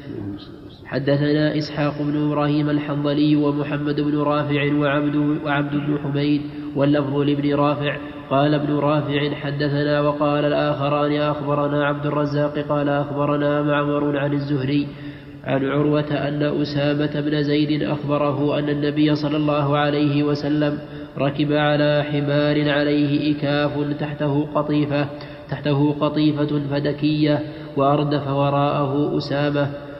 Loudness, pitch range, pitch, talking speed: -20 LUFS, 145-150 Hz, 145 Hz, 110 wpm